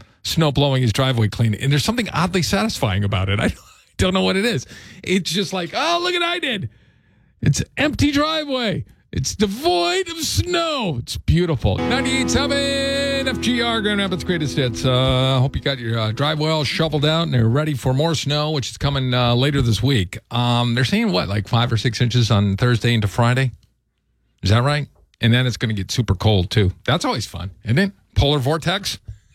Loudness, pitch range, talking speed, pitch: -19 LUFS, 110-180 Hz, 200 wpm, 130 Hz